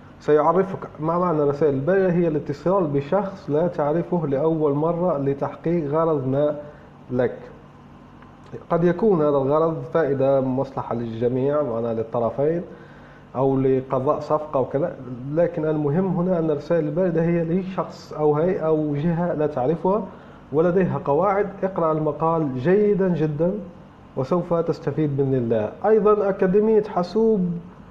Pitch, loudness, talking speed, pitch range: 160 Hz, -22 LUFS, 125 wpm, 145-175 Hz